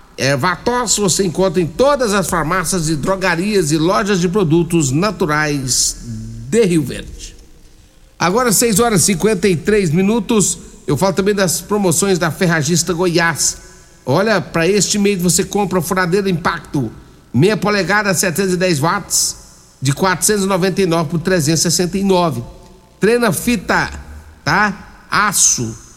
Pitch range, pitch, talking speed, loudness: 165-200 Hz, 185 Hz, 125 wpm, -15 LUFS